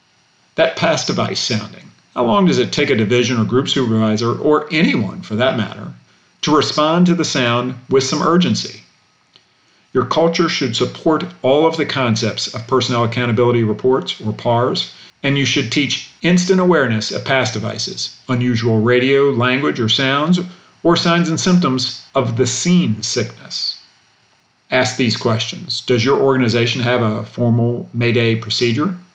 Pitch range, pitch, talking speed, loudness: 120-150 Hz, 130 Hz, 150 wpm, -16 LUFS